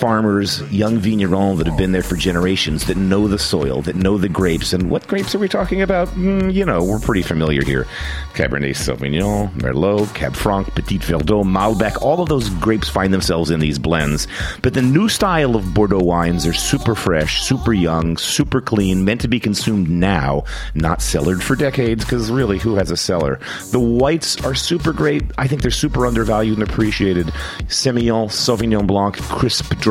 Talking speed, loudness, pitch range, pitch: 190 wpm, -17 LUFS, 90-120 Hz, 100 Hz